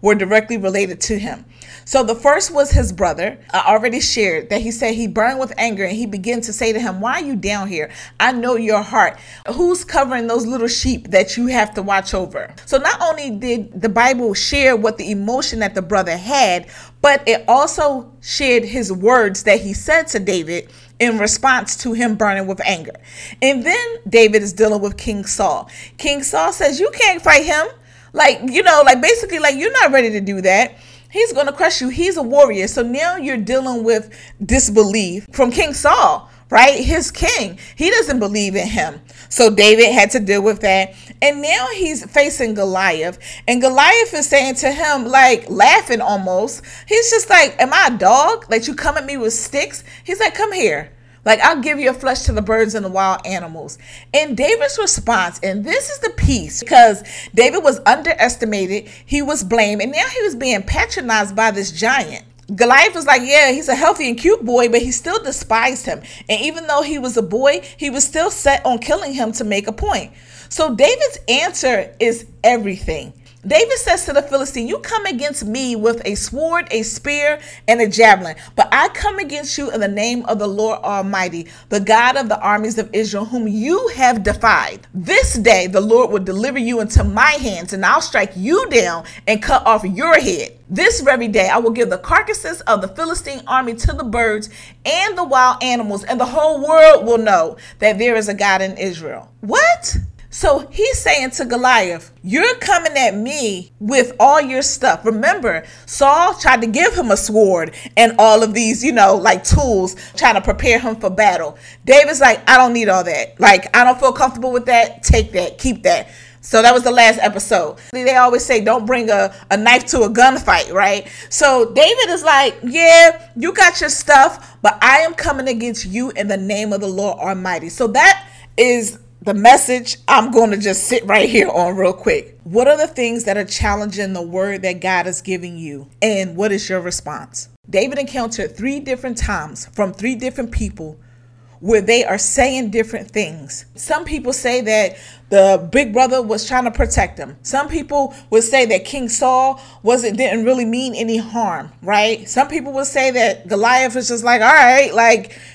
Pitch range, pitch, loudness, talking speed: 205-285 Hz, 240 Hz, -14 LUFS, 200 wpm